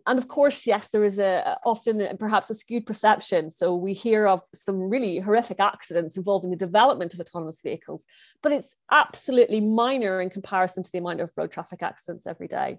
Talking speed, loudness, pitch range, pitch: 190 wpm, -24 LUFS, 185-225 Hz, 200 Hz